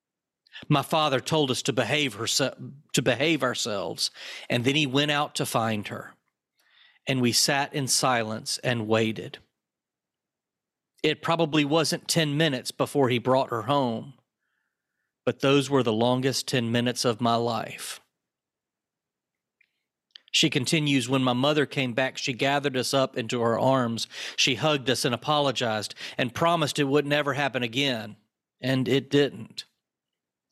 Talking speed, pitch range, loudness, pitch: 145 wpm, 120-145 Hz, -25 LUFS, 135 Hz